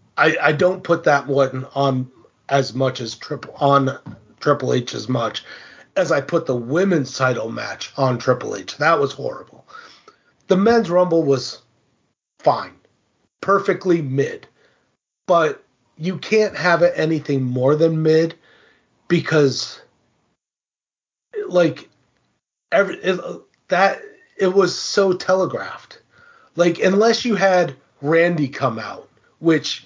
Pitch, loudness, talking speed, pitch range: 160 Hz, -19 LUFS, 125 wpm, 135-185 Hz